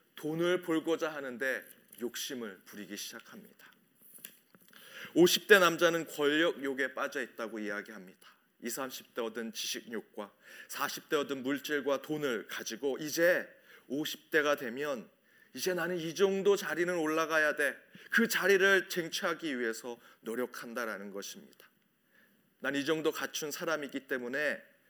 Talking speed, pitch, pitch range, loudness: 270 characters per minute, 155 Hz, 135-180 Hz, -32 LUFS